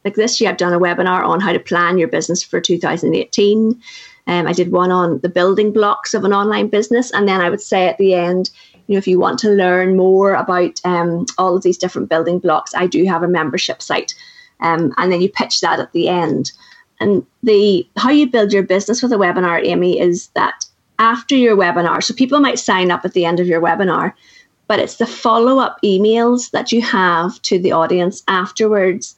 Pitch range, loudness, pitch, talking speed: 180-220 Hz, -15 LUFS, 190 Hz, 215 wpm